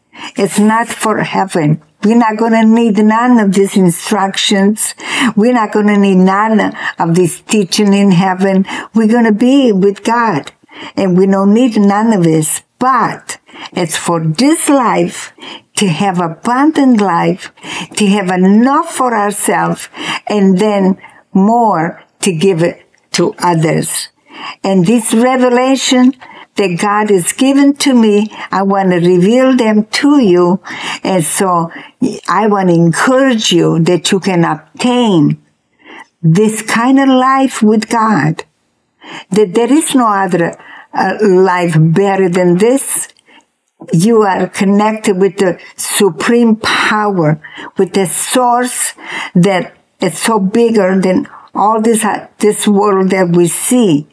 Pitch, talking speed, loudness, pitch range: 205 Hz, 135 wpm, -11 LUFS, 185-235 Hz